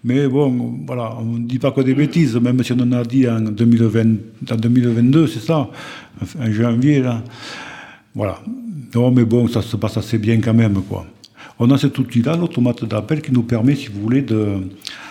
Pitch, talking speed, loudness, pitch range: 120 Hz, 200 wpm, -17 LUFS, 115-130 Hz